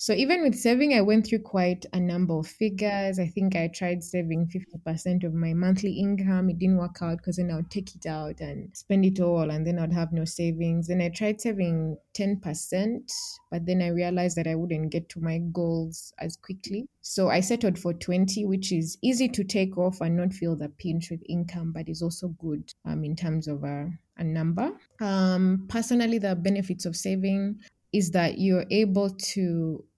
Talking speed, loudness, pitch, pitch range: 205 wpm, -27 LUFS, 180 Hz, 165-195 Hz